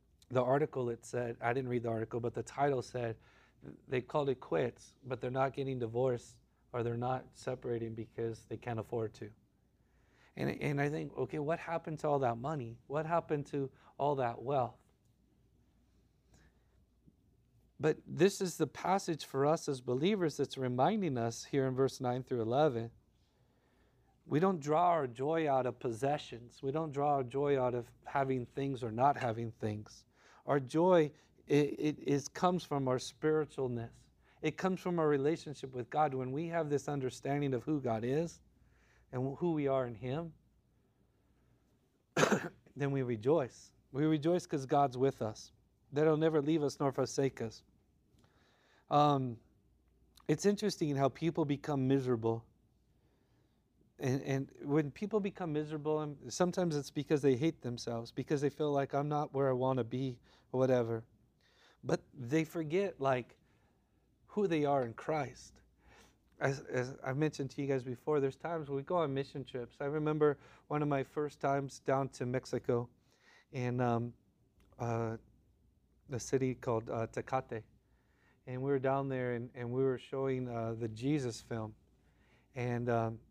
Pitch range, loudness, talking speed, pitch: 120-150 Hz, -35 LUFS, 160 wpm, 130 Hz